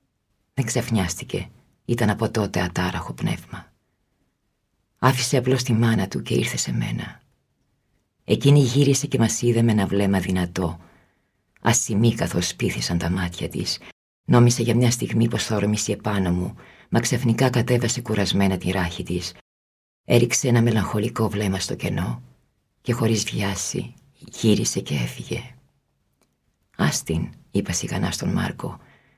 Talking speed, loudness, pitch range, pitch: 130 wpm, -22 LUFS, 95-120 Hz, 105 Hz